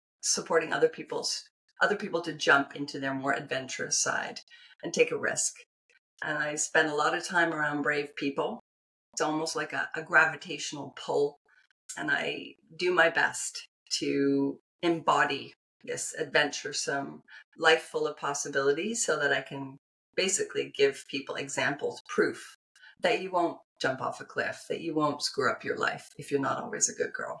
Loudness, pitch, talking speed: -29 LUFS, 160 Hz, 165 wpm